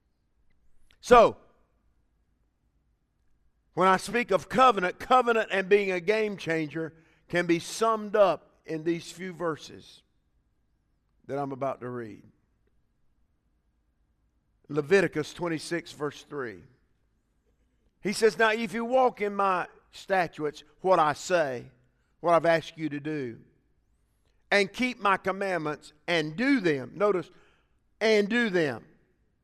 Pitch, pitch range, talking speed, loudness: 165 Hz, 135-200 Hz, 120 wpm, -26 LUFS